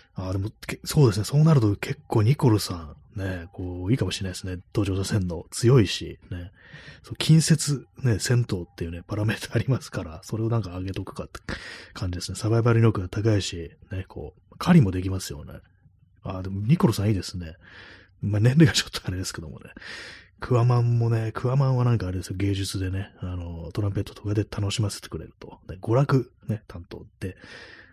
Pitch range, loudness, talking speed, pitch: 95-115 Hz, -25 LUFS, 405 characters per minute, 100 Hz